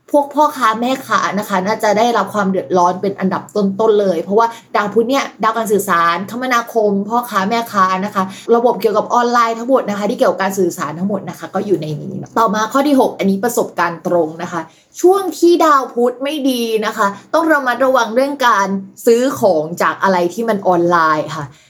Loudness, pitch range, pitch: -15 LUFS, 185-240 Hz, 215 Hz